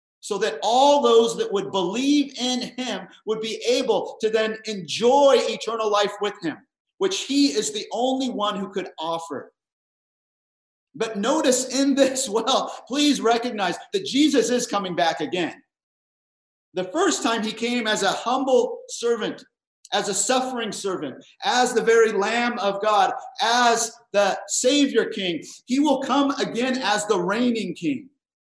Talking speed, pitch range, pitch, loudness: 150 wpm, 210-275 Hz, 235 Hz, -22 LUFS